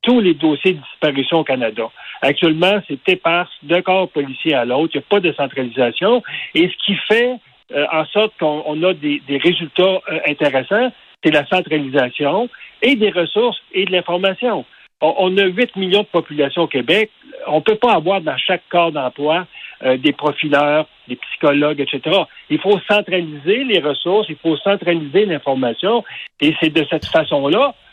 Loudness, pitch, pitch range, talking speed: -16 LUFS, 170 Hz, 150-200 Hz, 180 wpm